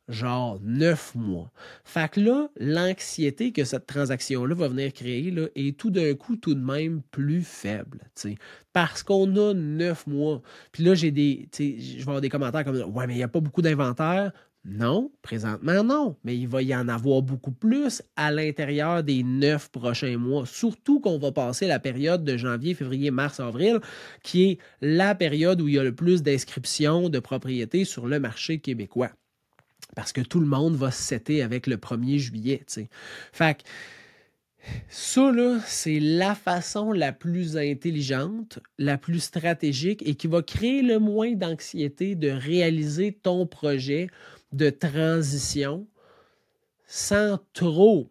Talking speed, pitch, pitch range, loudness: 165 wpm, 150 Hz, 135-180 Hz, -25 LUFS